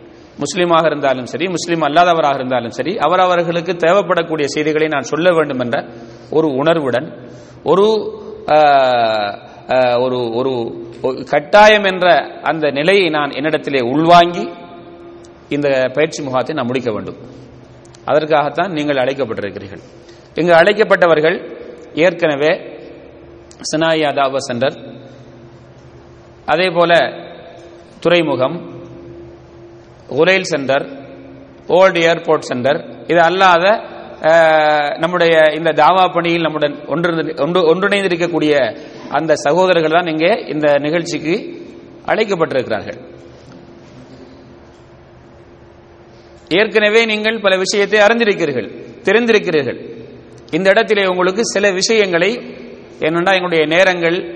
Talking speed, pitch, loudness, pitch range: 85 wpm, 160 Hz, -14 LUFS, 140-180 Hz